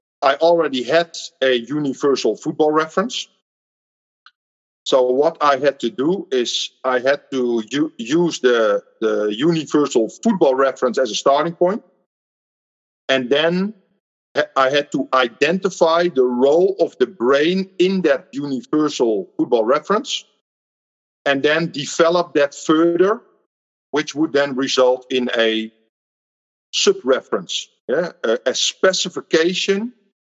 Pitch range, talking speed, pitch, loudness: 135-190 Hz, 115 wpm, 155 Hz, -18 LUFS